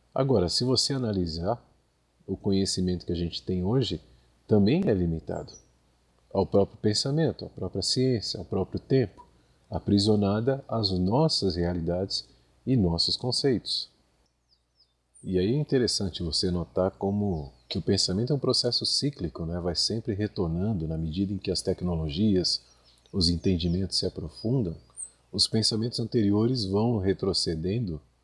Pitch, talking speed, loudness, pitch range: 95 Hz, 135 wpm, -27 LUFS, 85-110 Hz